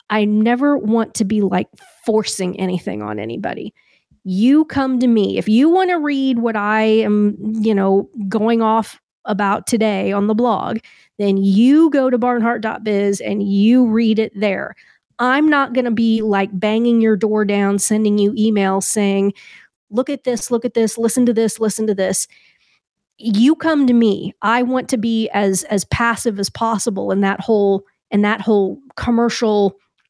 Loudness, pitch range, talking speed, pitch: -16 LUFS, 200-235 Hz, 175 wpm, 220 Hz